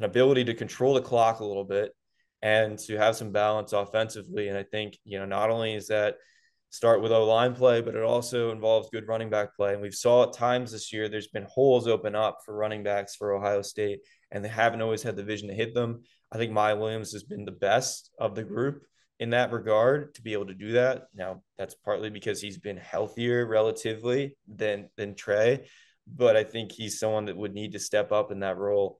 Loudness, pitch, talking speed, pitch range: -27 LUFS, 110 Hz, 225 wpm, 105-115 Hz